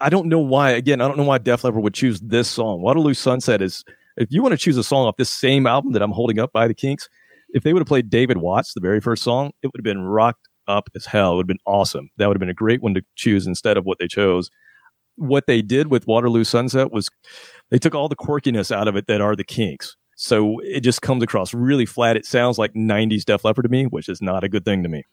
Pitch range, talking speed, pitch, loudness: 105-130 Hz, 275 wpm, 115 Hz, -19 LUFS